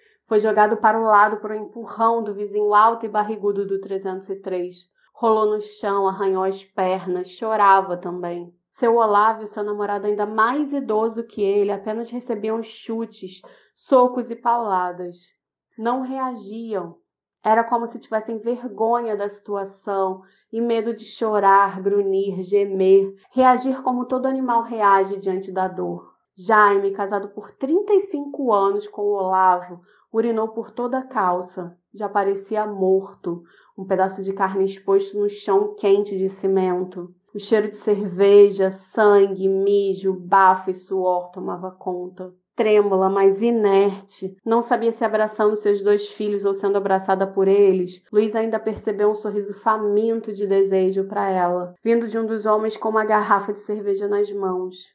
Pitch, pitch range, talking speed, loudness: 205 Hz, 195-220 Hz, 145 wpm, -20 LUFS